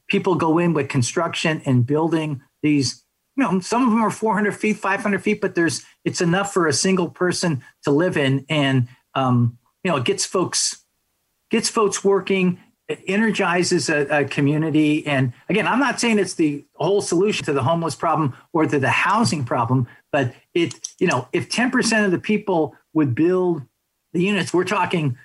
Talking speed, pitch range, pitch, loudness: 190 wpm, 145-195 Hz, 165 Hz, -20 LUFS